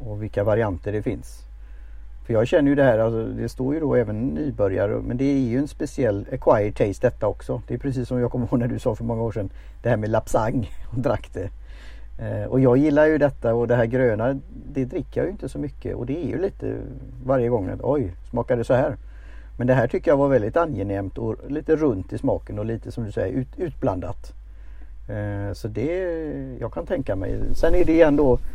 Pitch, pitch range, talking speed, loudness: 120 Hz, 105-135 Hz, 230 wpm, -23 LUFS